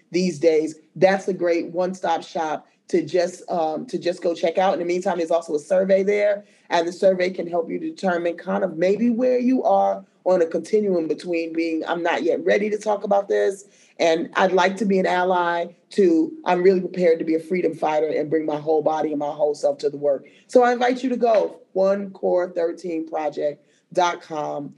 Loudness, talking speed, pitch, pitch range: -22 LUFS, 210 wpm, 175 Hz, 160-195 Hz